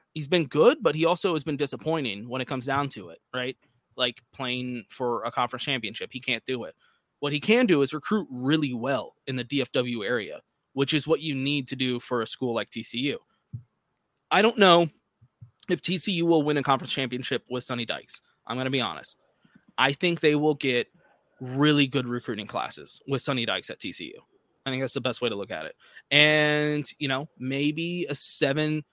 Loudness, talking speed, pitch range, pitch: -26 LUFS, 205 wpm, 125-150 Hz, 135 Hz